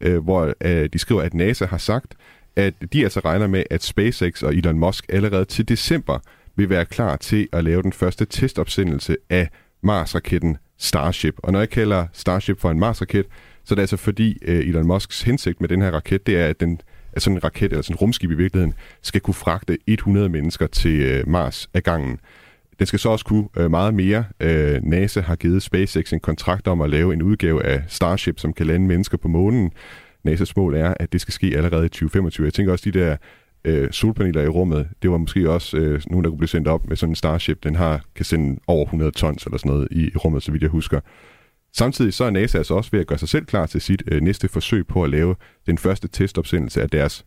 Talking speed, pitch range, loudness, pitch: 220 wpm, 80-100 Hz, -20 LUFS, 90 Hz